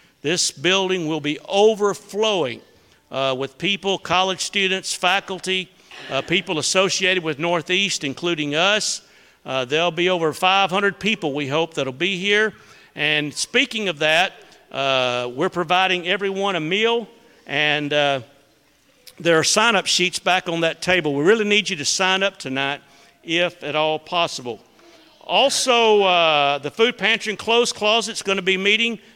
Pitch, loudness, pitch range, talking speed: 180 Hz, -19 LUFS, 150-200 Hz, 155 wpm